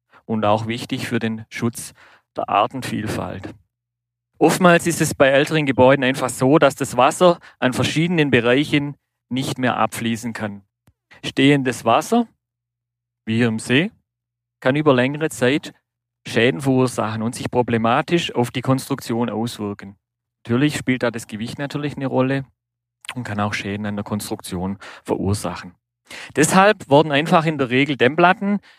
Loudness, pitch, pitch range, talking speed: -19 LUFS, 125 Hz, 115-140 Hz, 140 wpm